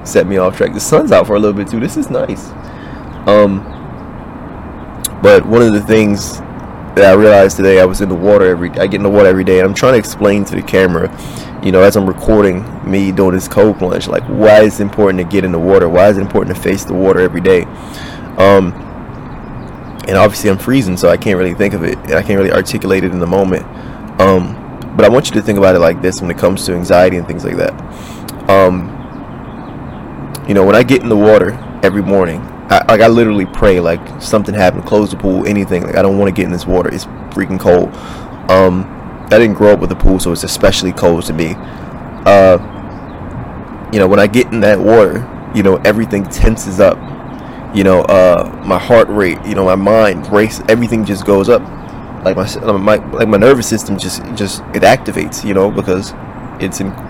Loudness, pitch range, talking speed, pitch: -11 LUFS, 90-105 Hz, 220 wpm, 95 Hz